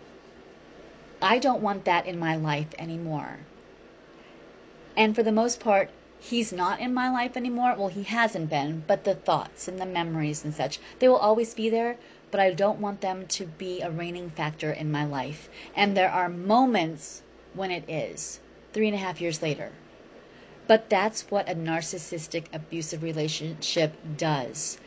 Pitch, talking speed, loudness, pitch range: 180 Hz, 170 wpm, -27 LUFS, 160-215 Hz